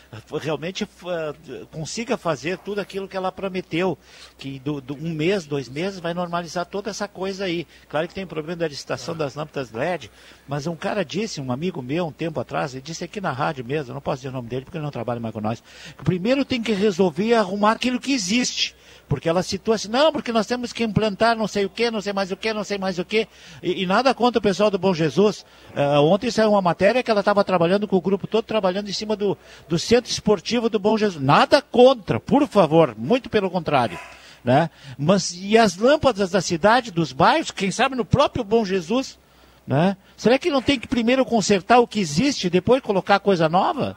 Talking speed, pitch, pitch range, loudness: 225 wpm, 195 Hz, 165-220 Hz, -21 LUFS